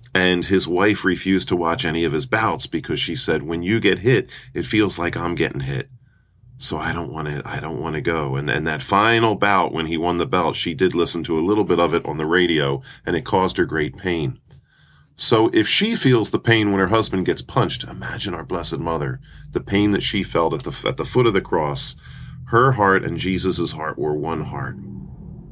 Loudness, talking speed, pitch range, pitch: -19 LUFS, 230 wpm, 80-105 Hz, 90 Hz